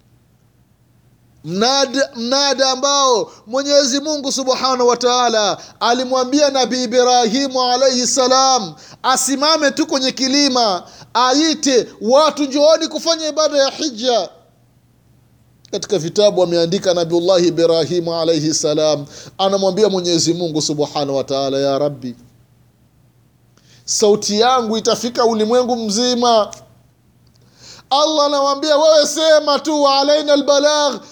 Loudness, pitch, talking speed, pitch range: -15 LUFS, 245 Hz, 95 wpm, 175-280 Hz